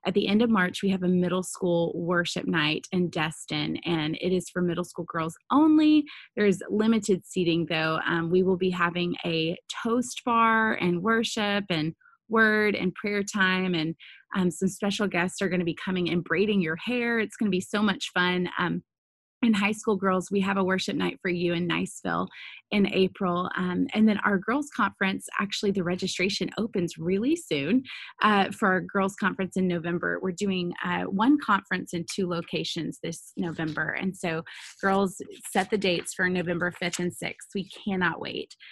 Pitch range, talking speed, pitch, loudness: 175-205 Hz, 190 wpm, 185 Hz, -26 LUFS